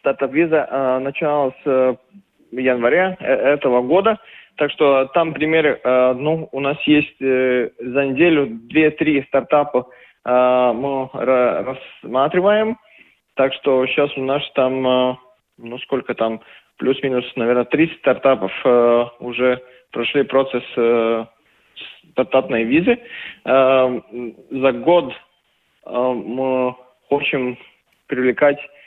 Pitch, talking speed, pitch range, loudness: 130 Hz, 115 wpm, 125-145 Hz, -18 LUFS